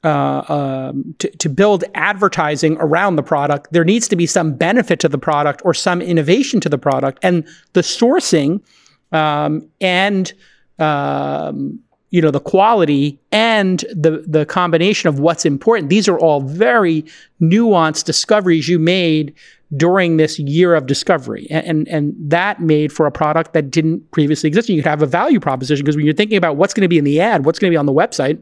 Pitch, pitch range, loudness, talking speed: 165 Hz, 150-185 Hz, -15 LUFS, 195 wpm